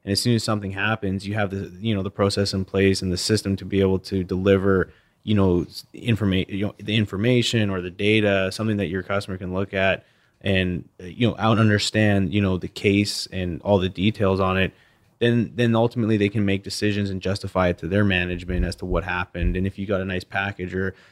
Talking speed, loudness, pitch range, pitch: 225 wpm, -23 LUFS, 95-105 Hz, 100 Hz